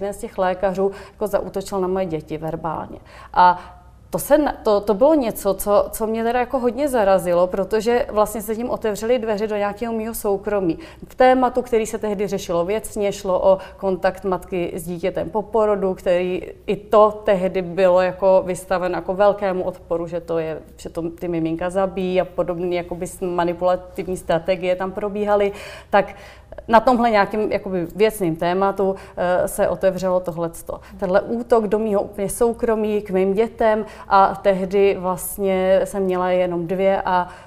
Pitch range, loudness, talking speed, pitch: 180-215 Hz, -20 LUFS, 160 wpm, 195 Hz